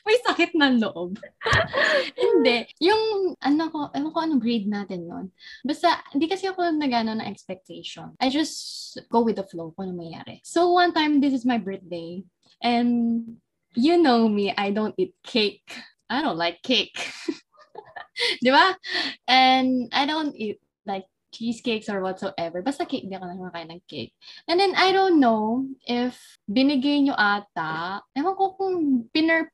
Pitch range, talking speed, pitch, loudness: 205-320 Hz, 165 wpm, 255 Hz, -23 LUFS